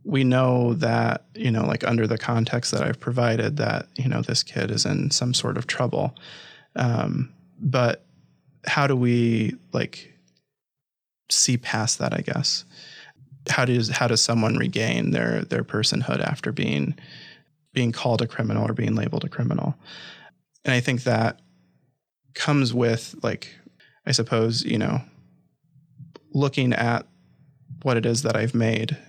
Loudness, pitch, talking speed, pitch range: -23 LUFS, 120 Hz, 150 wpm, 115-135 Hz